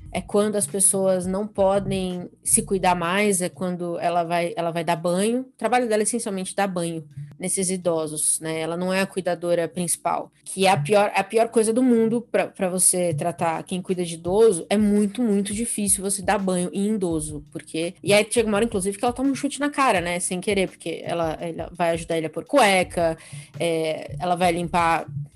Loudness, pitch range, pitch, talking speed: -22 LUFS, 170-205 Hz, 185 Hz, 210 wpm